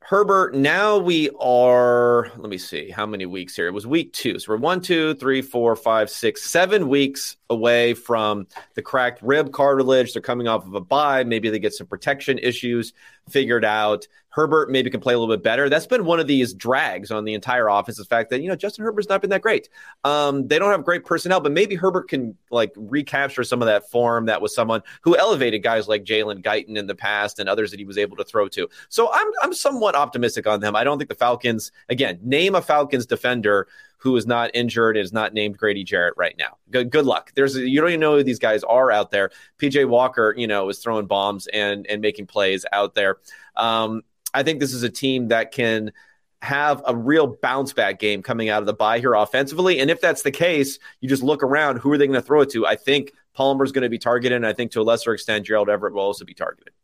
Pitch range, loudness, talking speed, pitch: 110-145 Hz, -20 LUFS, 240 wpm, 125 Hz